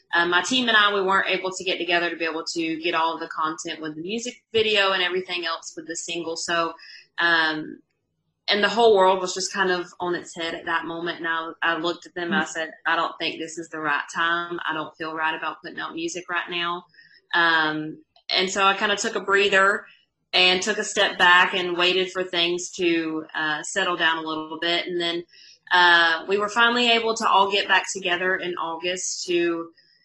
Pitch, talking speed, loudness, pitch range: 175 Hz, 225 wpm, -22 LUFS, 165-190 Hz